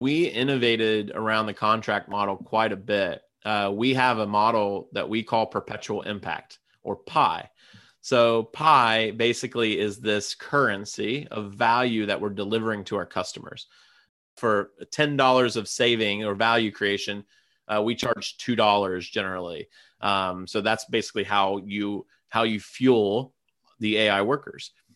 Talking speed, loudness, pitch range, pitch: 140 wpm, -24 LUFS, 100-115 Hz, 110 Hz